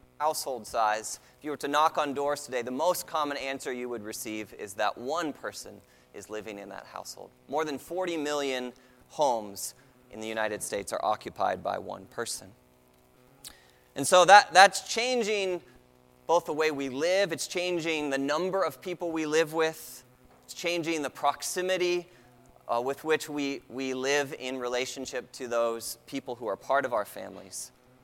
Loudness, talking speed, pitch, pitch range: -28 LUFS, 170 wpm, 135 Hz, 120-160 Hz